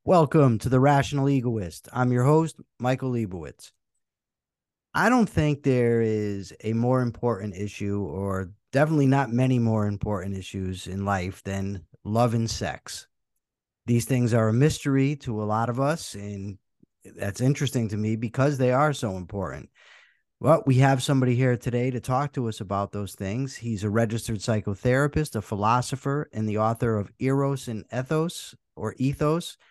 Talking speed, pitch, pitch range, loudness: 160 wpm, 120 Hz, 105-135 Hz, -25 LUFS